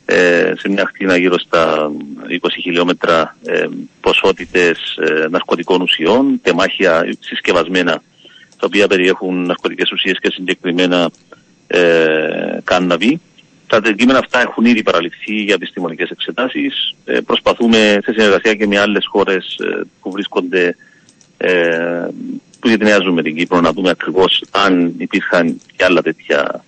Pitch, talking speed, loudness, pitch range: 90 Hz, 125 wpm, -14 LUFS, 85-105 Hz